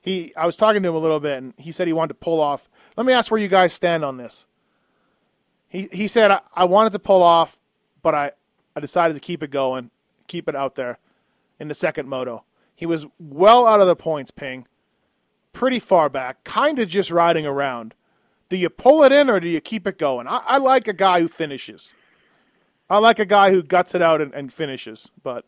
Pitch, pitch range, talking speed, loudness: 170 Hz, 150-210 Hz, 230 wpm, -18 LUFS